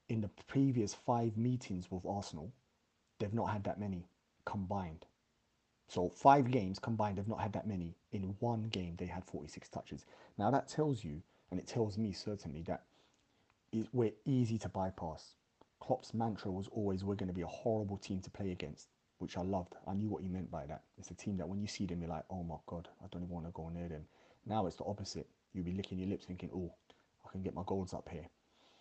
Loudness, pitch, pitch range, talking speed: -40 LUFS, 95 Hz, 90-110 Hz, 220 wpm